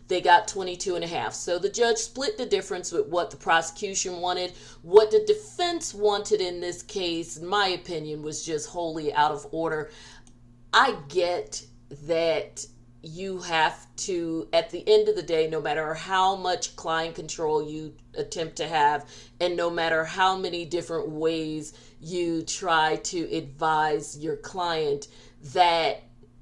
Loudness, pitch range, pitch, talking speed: -26 LUFS, 155-190 Hz, 170 Hz, 155 wpm